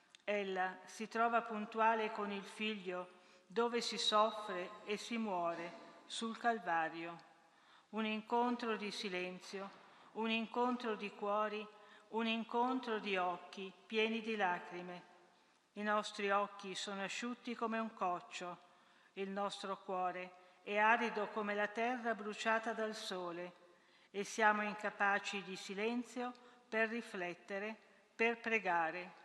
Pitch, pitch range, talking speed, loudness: 210 Hz, 180-225 Hz, 120 wpm, -39 LUFS